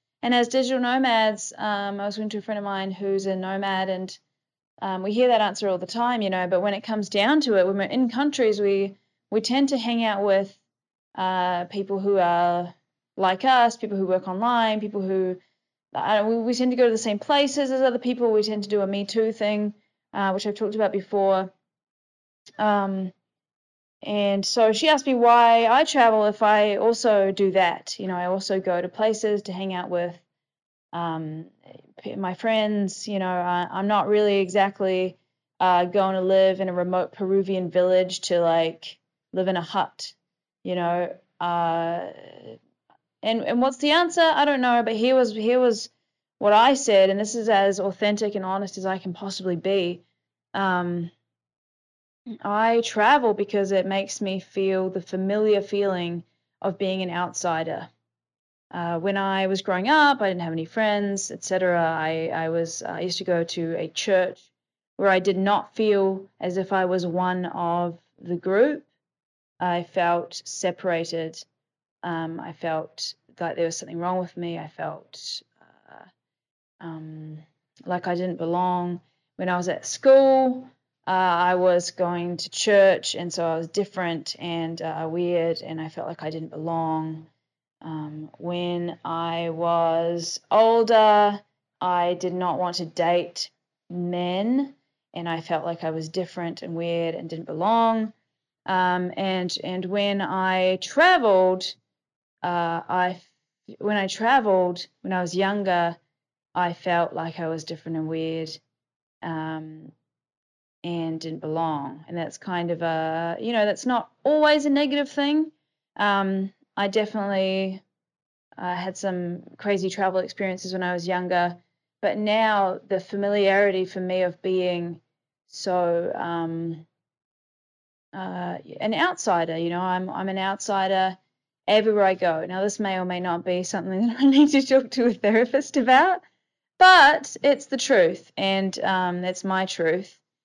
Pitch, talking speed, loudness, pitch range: 190 Hz, 165 wpm, -23 LUFS, 175-210 Hz